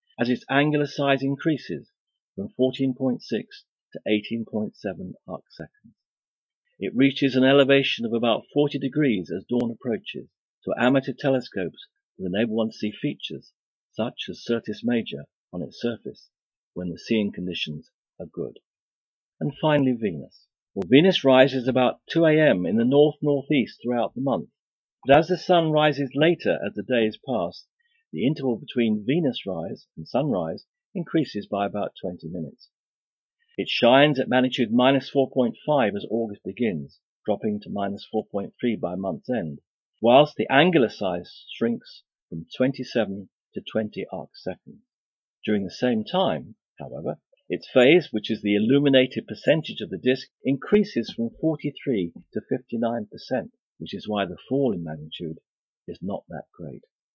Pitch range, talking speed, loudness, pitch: 110-145 Hz, 145 wpm, -24 LUFS, 130 Hz